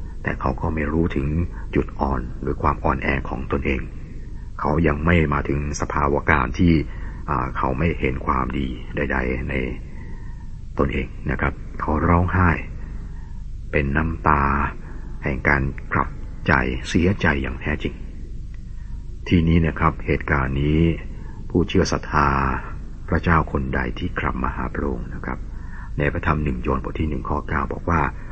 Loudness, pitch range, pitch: -22 LUFS, 70-80 Hz, 75 Hz